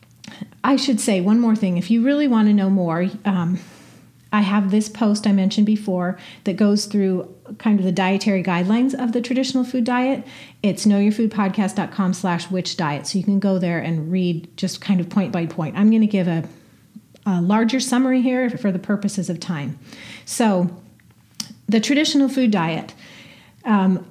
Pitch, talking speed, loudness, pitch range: 200 Hz, 180 wpm, -20 LUFS, 185-220 Hz